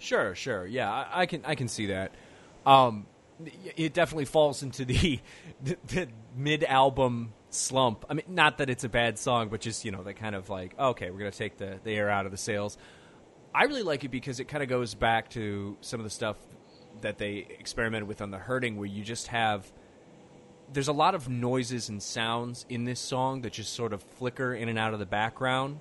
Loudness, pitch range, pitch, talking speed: -30 LUFS, 105-135 Hz, 120 Hz, 220 wpm